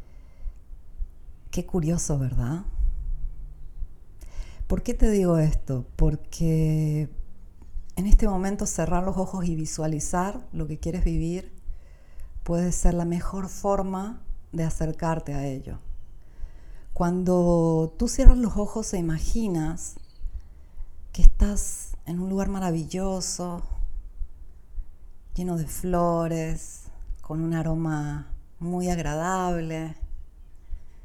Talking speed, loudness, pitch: 100 wpm, -27 LUFS, 155 Hz